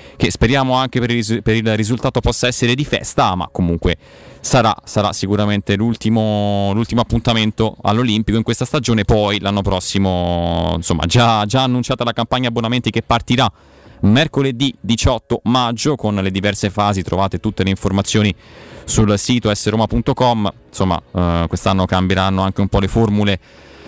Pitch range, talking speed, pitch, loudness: 95-120 Hz, 150 wpm, 110 Hz, -16 LUFS